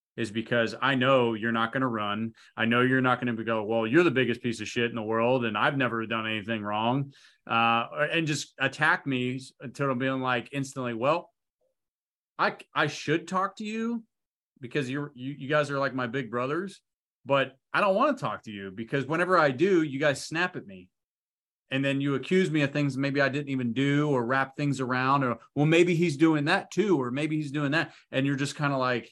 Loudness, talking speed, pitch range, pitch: -27 LUFS, 225 wpm, 120-150 Hz, 135 Hz